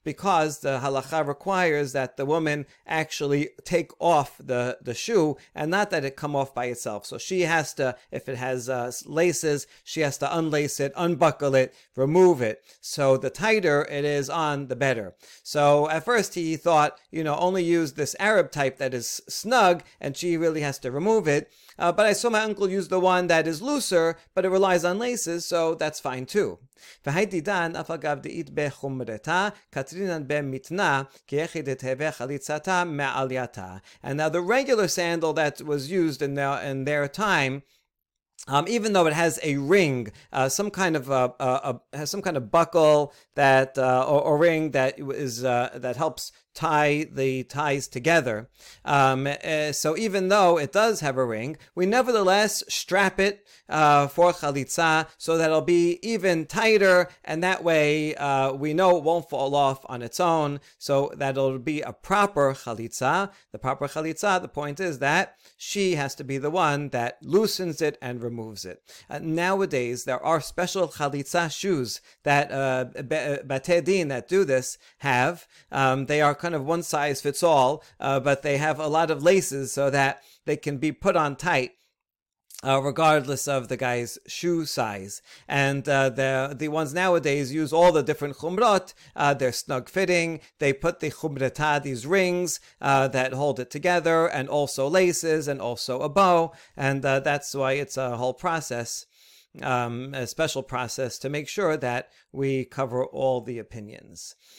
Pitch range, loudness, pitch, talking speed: 135-170 Hz, -24 LUFS, 145 Hz, 170 wpm